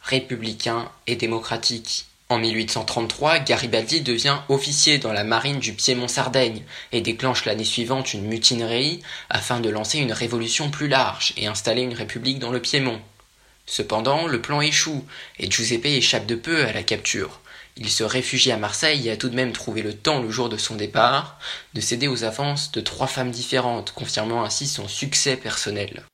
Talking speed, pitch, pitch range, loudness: 175 wpm, 120 Hz, 110-135 Hz, -22 LUFS